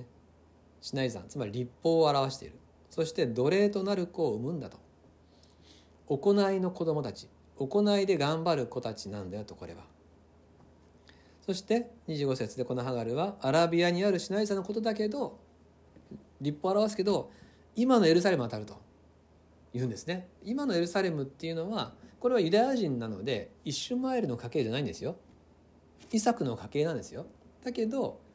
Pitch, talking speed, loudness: 135 Hz, 345 characters per minute, -31 LUFS